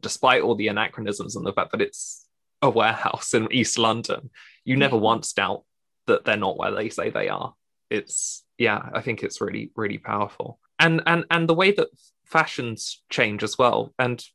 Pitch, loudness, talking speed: 165 Hz, -23 LUFS, 190 wpm